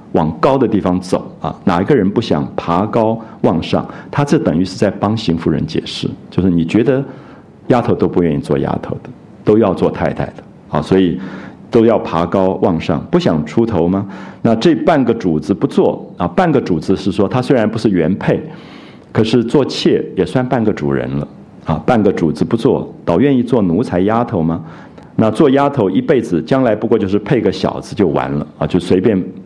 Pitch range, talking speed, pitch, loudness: 85-115 Hz, 280 characters per minute, 95 Hz, -15 LUFS